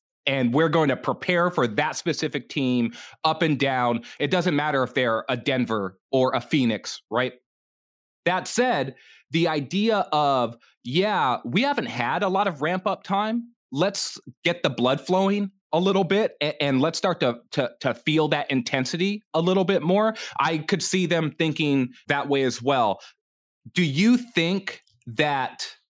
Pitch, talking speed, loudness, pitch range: 160 Hz, 165 wpm, -24 LUFS, 130-190 Hz